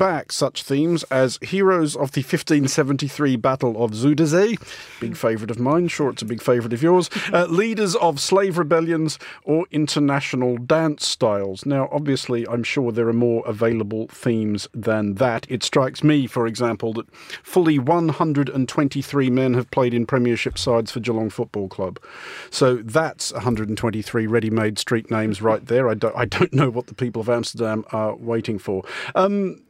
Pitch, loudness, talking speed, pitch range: 130 Hz, -21 LUFS, 165 wpm, 115-155 Hz